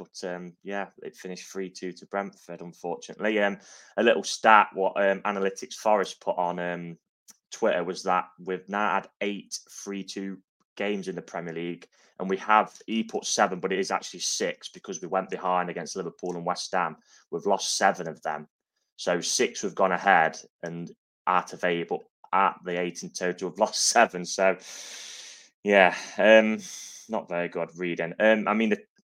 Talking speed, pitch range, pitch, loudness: 175 wpm, 90-100 Hz, 90 Hz, -26 LUFS